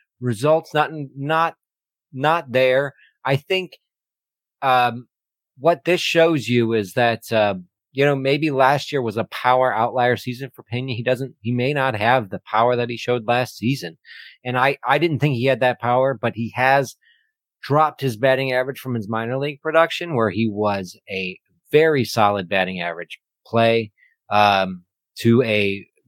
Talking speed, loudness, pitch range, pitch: 170 wpm, -20 LUFS, 115-140 Hz, 125 Hz